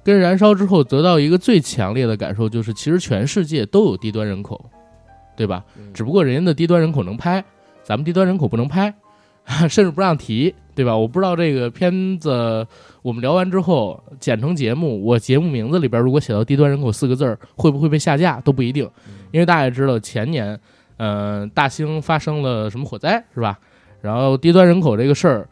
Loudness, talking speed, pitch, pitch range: -17 LUFS, 320 characters per minute, 135 Hz, 115-175 Hz